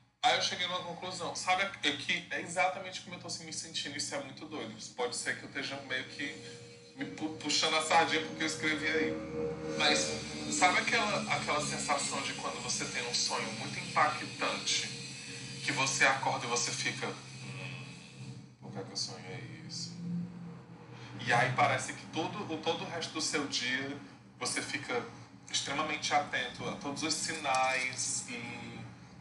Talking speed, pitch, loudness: 170 wpm, 150 Hz, -33 LUFS